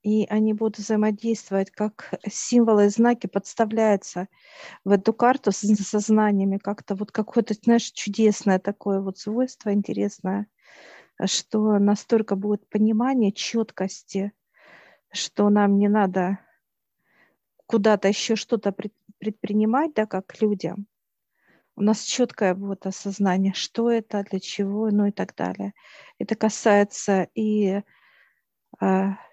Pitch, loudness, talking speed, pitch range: 210 Hz, -23 LUFS, 115 wpm, 195-220 Hz